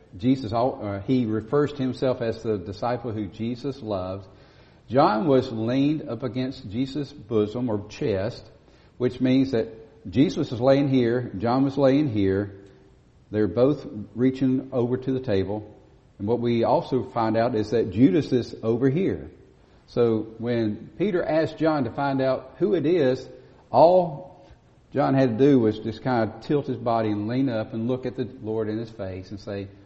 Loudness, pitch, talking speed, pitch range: -24 LUFS, 120 Hz, 175 wpm, 110-135 Hz